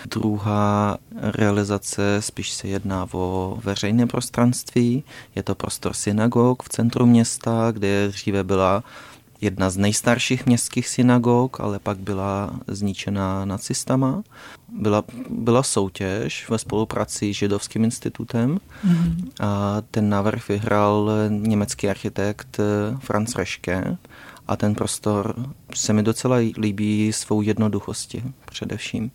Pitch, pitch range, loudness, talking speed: 105 Hz, 100-120 Hz, -22 LUFS, 110 wpm